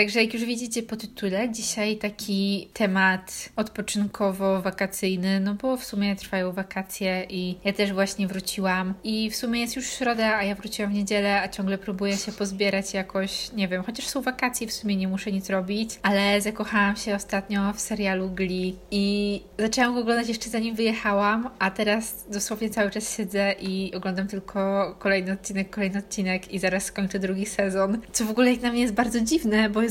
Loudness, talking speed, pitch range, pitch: -26 LUFS, 185 wpm, 195-220 Hz, 200 Hz